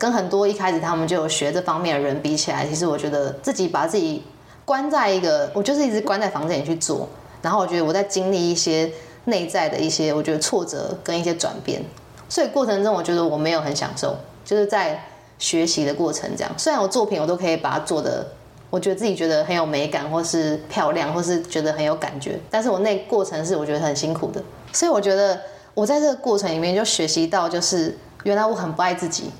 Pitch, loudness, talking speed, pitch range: 175 Hz, -22 LUFS, 350 characters per minute, 155-200 Hz